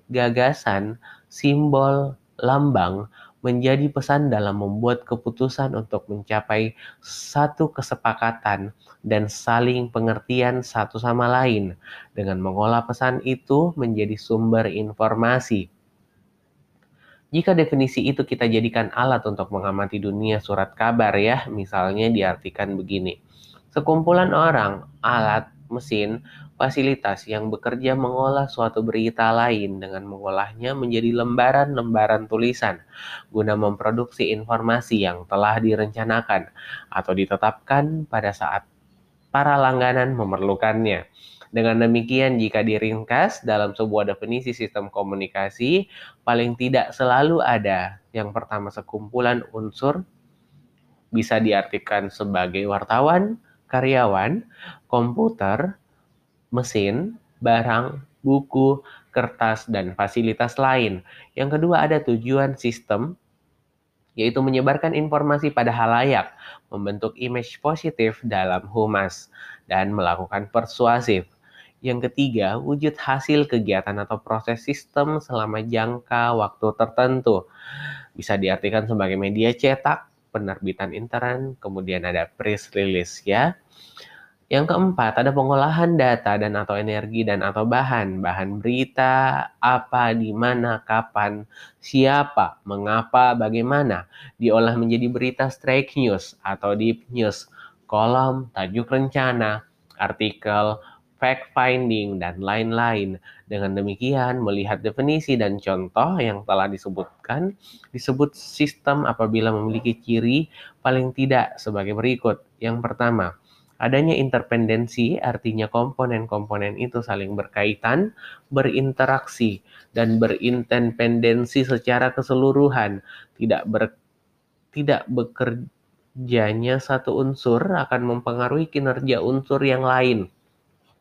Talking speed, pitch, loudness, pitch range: 100 wpm, 115 Hz, -22 LUFS, 105-130 Hz